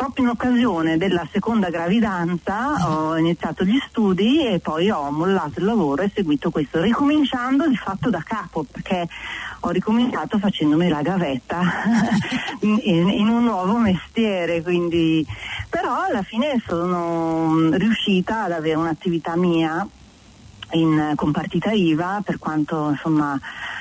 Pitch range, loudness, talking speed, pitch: 160-215 Hz, -21 LUFS, 130 wpm, 175 Hz